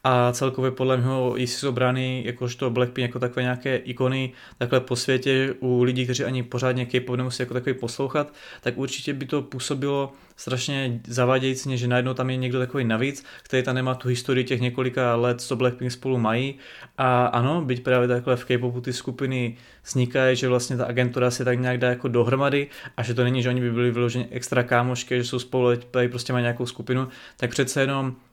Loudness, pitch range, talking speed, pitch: -24 LUFS, 125-130 Hz, 195 wpm, 125 Hz